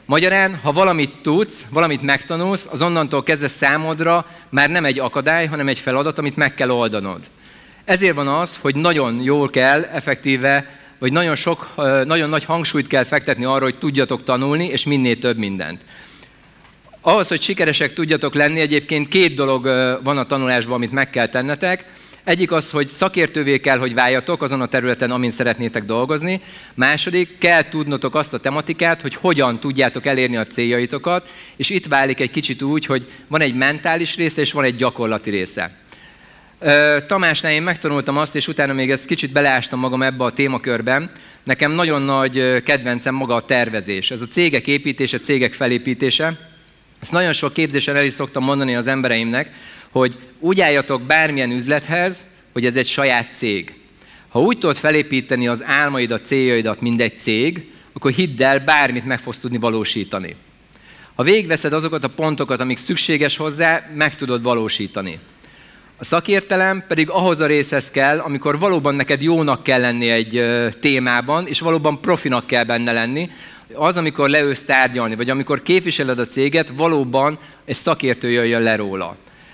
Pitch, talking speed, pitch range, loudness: 140 Hz, 160 wpm, 125-155 Hz, -17 LUFS